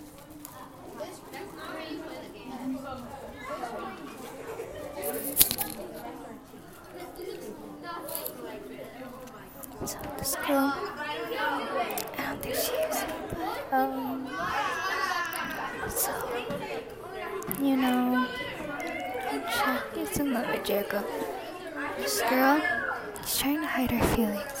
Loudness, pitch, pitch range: -30 LUFS, 275 Hz, 255-355 Hz